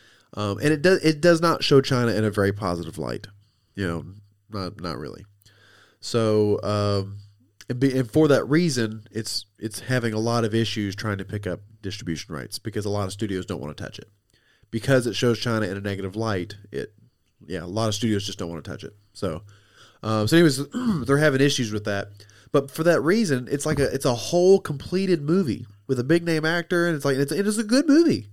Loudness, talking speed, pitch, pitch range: -23 LUFS, 220 wpm, 110 Hz, 100-140 Hz